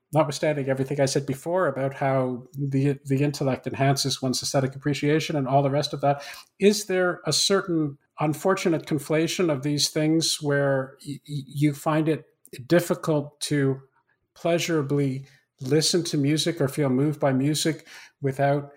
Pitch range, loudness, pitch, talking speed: 135-155 Hz, -24 LUFS, 145 Hz, 145 wpm